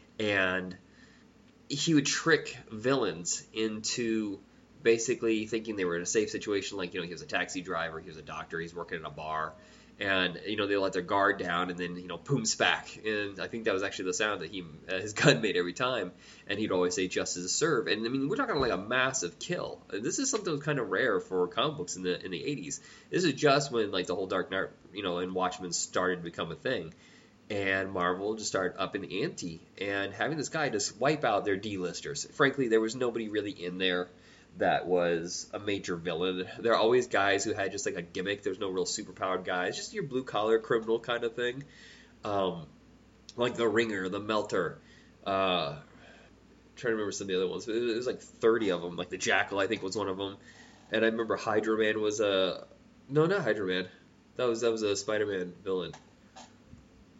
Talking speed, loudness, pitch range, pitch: 220 wpm, -31 LUFS, 90-115 Hz, 105 Hz